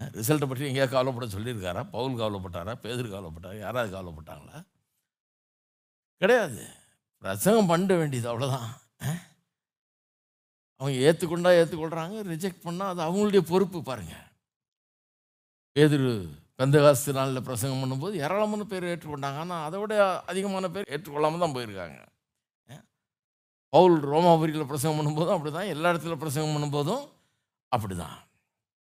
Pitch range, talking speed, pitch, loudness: 125-175 Hz, 110 wpm, 150 Hz, -27 LUFS